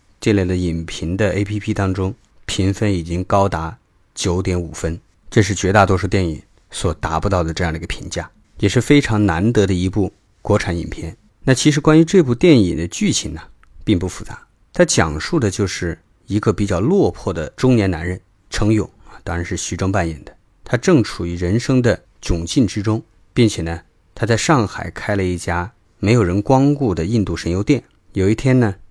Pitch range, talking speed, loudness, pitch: 85-110 Hz, 280 characters per minute, -18 LUFS, 100 Hz